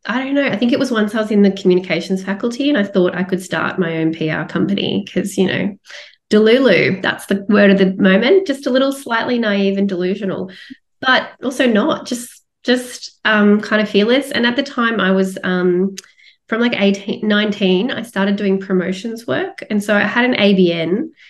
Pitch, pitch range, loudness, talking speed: 205 Hz, 190-240 Hz, -16 LUFS, 205 wpm